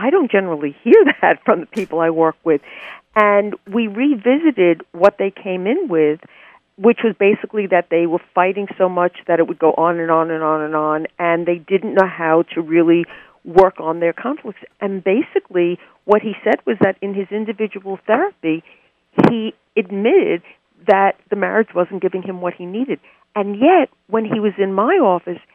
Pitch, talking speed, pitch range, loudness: 195 Hz, 190 wpm, 170-215 Hz, -17 LUFS